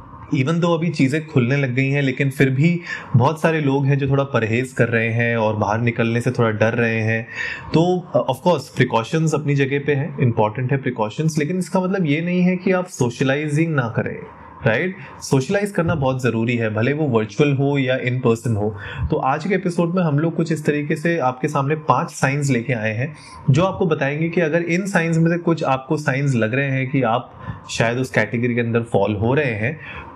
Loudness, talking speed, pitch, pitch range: -19 LUFS, 220 wpm, 140 Hz, 120-160 Hz